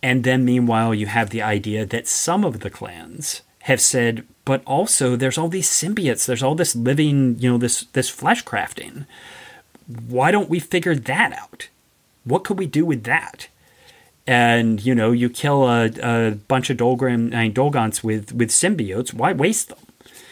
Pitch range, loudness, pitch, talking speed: 115-145 Hz, -19 LUFS, 125 Hz, 170 wpm